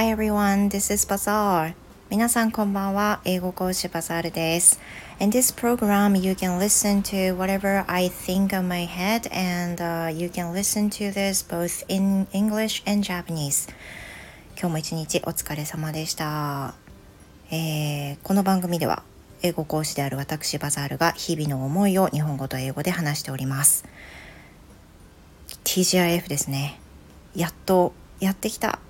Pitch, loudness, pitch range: 175 Hz, -23 LUFS, 150-195 Hz